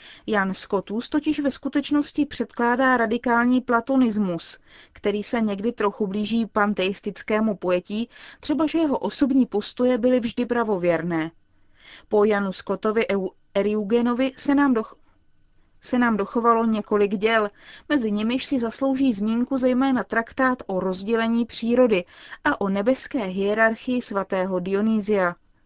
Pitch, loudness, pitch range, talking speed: 230 Hz, -23 LUFS, 205-255 Hz, 115 wpm